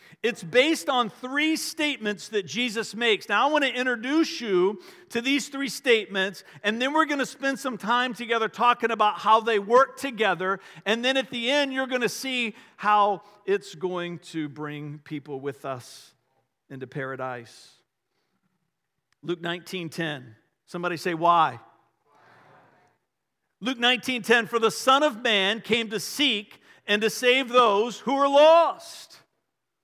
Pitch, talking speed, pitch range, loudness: 220 Hz, 150 wpm, 180-260 Hz, -24 LUFS